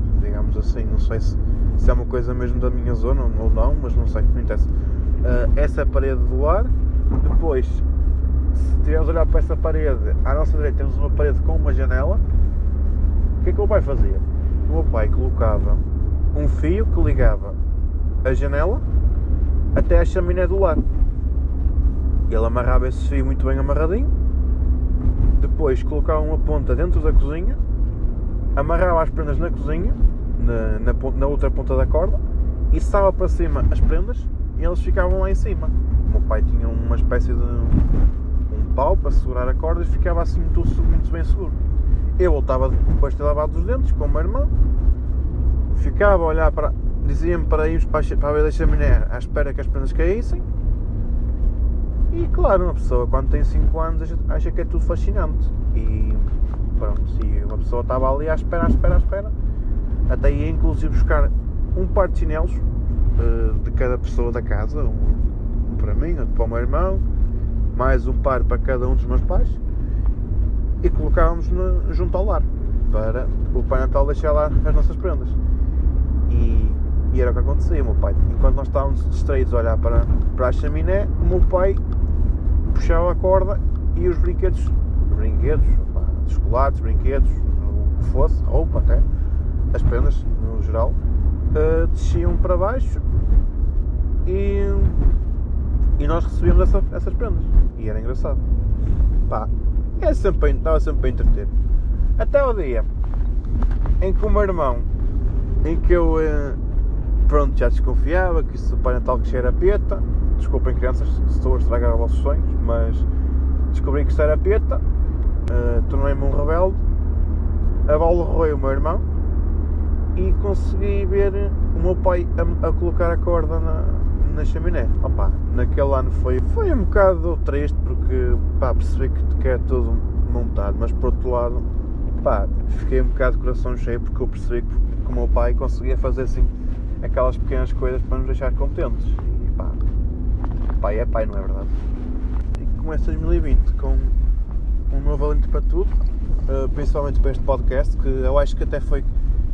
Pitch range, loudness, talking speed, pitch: 65-80 Hz, -21 LUFS, 165 wpm, 70 Hz